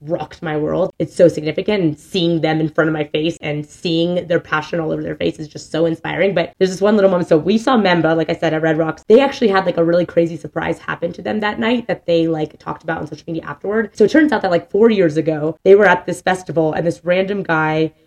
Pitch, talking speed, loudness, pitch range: 170 Hz, 270 wpm, -17 LUFS, 160-190 Hz